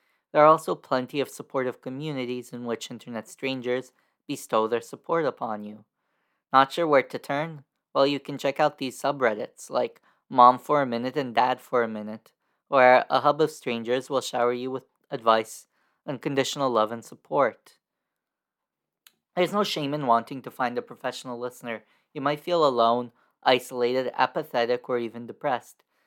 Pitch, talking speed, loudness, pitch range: 130 Hz, 165 wpm, -25 LUFS, 120-145 Hz